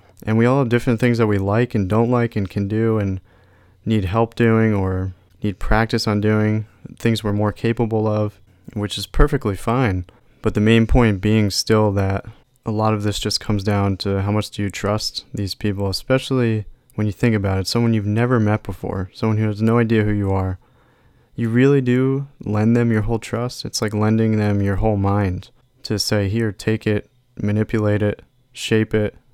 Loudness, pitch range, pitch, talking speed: -20 LUFS, 100-115 Hz, 110 Hz, 200 wpm